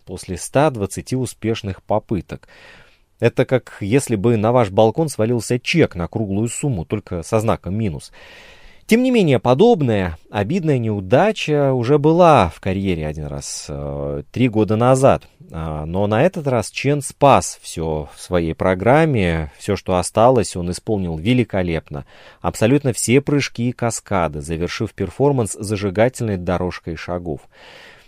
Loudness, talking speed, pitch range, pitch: -18 LUFS, 130 wpm, 90-130 Hz, 110 Hz